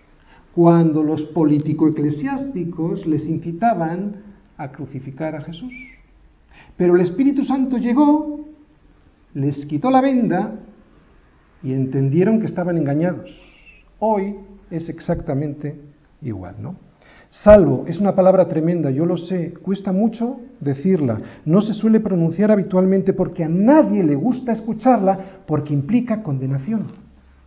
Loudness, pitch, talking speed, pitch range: -18 LUFS, 180 Hz, 120 wpm, 150-215 Hz